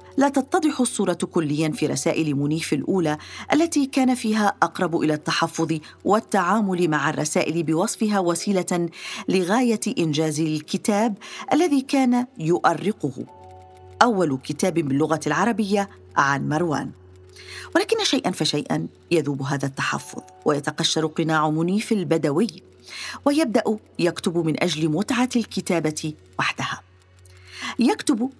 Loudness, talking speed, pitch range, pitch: -22 LUFS, 105 wpm, 155-220 Hz, 170 Hz